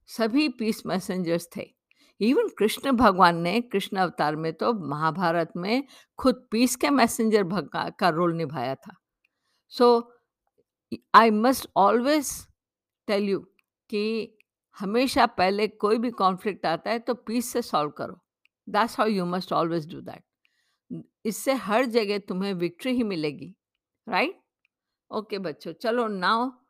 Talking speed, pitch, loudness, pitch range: 135 wpm, 215 Hz, -25 LUFS, 180-240 Hz